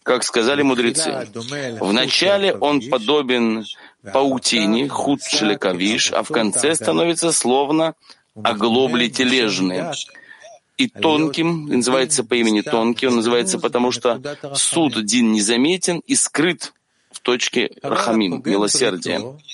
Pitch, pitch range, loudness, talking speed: 130 Hz, 120-155 Hz, -18 LUFS, 105 wpm